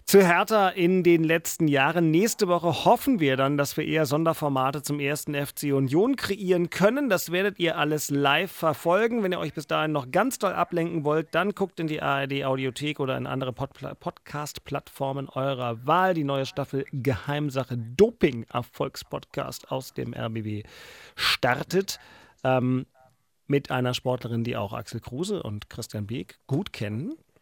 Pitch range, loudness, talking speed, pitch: 130-175 Hz, -26 LUFS, 155 wpm, 145 Hz